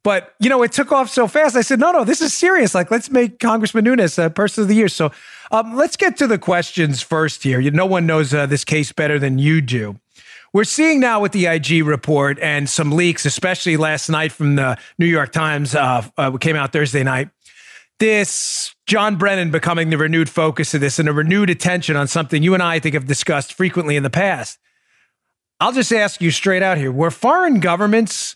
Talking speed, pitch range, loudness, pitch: 220 wpm, 155-225 Hz, -16 LUFS, 170 Hz